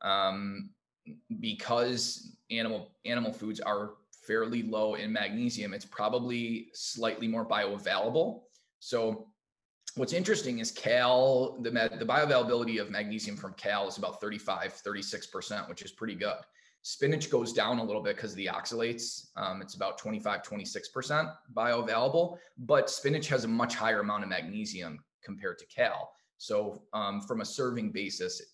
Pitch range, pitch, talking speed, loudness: 110-155 Hz, 120 Hz, 150 wpm, -32 LUFS